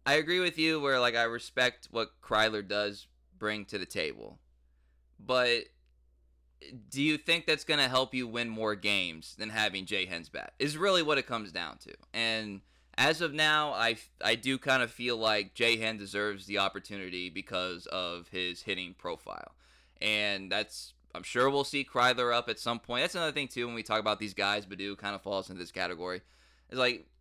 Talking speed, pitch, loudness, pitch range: 195 wpm, 105 Hz, -31 LUFS, 90-125 Hz